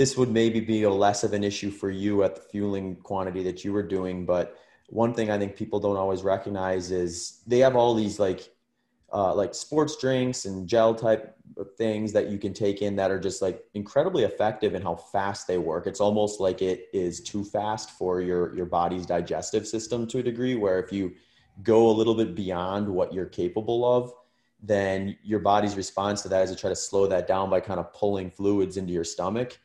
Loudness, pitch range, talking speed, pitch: -26 LUFS, 95-110 Hz, 215 wpm, 100 Hz